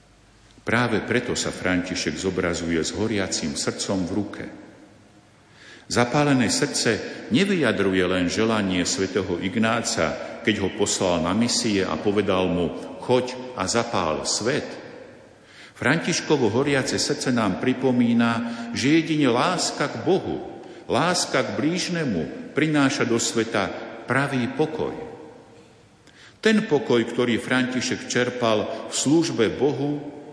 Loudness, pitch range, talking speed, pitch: -23 LUFS, 100-130 Hz, 110 wpm, 115 Hz